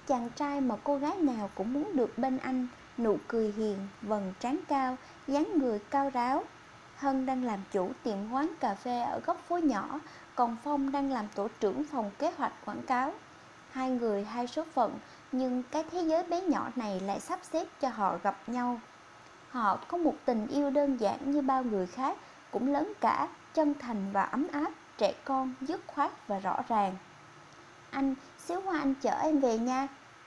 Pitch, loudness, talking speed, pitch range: 265 Hz, -32 LUFS, 190 wpm, 225-290 Hz